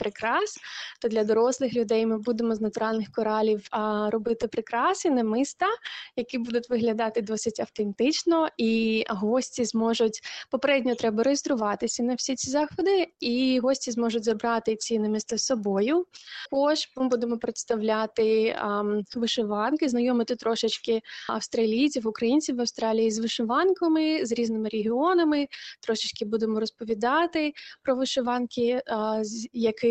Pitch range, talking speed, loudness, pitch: 225-265 Hz, 125 wpm, -26 LUFS, 235 Hz